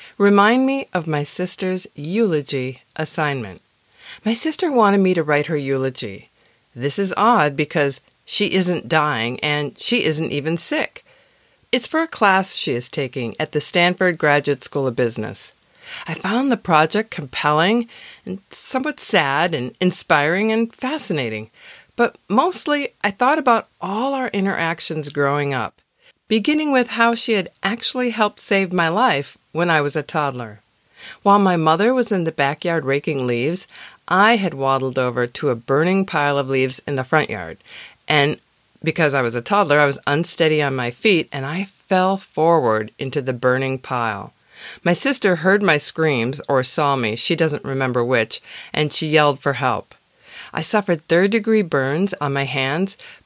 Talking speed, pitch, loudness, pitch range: 165 wpm, 160 Hz, -19 LUFS, 140-205 Hz